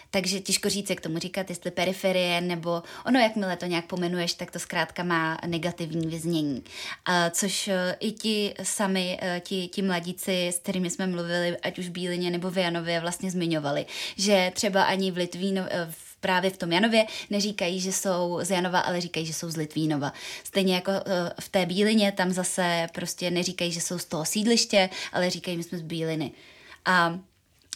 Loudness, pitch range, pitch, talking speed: -27 LUFS, 175-195 Hz, 180 Hz, 175 wpm